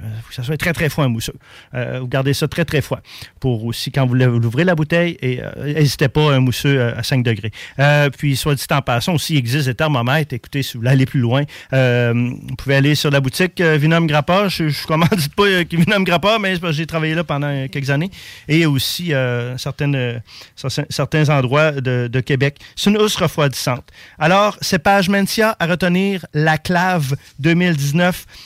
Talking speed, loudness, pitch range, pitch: 205 wpm, -17 LUFS, 130-165 Hz, 145 Hz